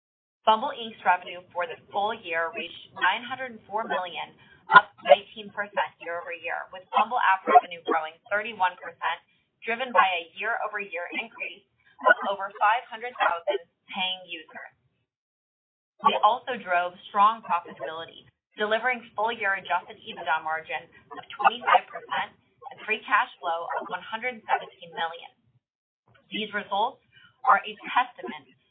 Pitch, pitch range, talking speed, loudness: 205 Hz, 175-230 Hz, 110 wpm, -26 LUFS